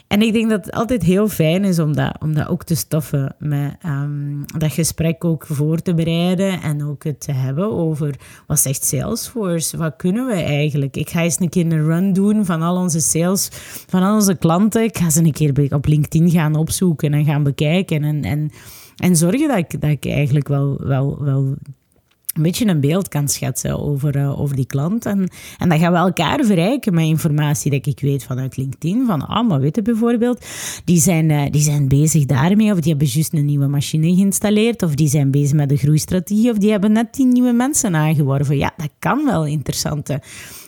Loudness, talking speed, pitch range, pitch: -17 LUFS, 210 wpm, 145-185 Hz, 155 Hz